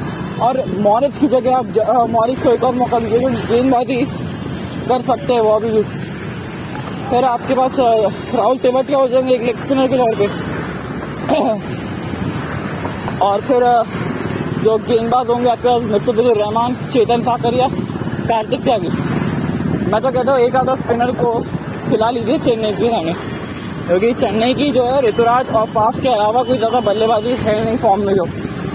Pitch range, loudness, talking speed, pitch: 220-255 Hz, -16 LUFS, 155 wpm, 235 Hz